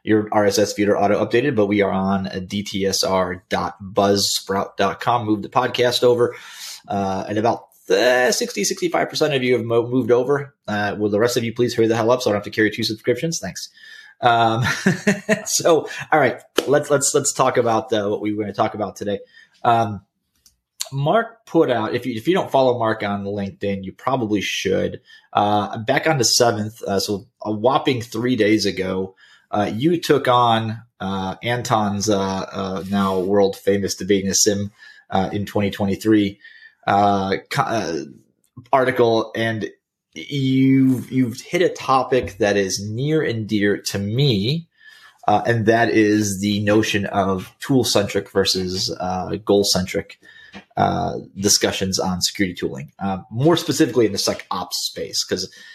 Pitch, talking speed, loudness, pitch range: 110 Hz, 165 wpm, -20 LUFS, 100-125 Hz